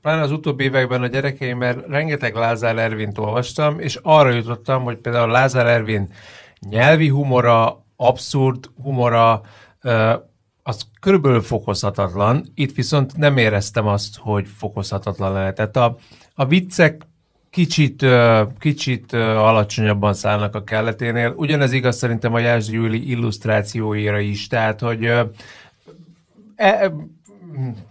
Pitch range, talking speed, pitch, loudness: 110-135 Hz, 115 wpm, 120 Hz, -18 LUFS